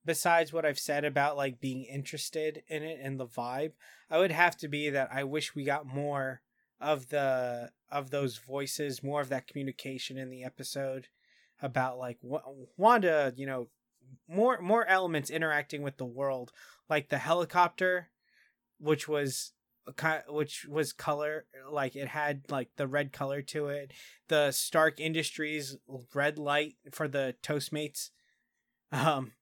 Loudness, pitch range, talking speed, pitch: -32 LUFS, 130-155 Hz, 155 wpm, 145 Hz